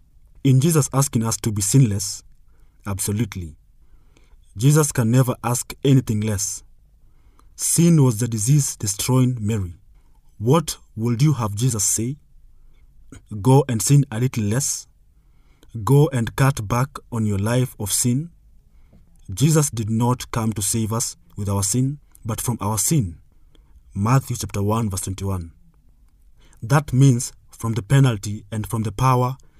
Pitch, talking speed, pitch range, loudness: 115 Hz, 140 wpm, 105-130 Hz, -20 LUFS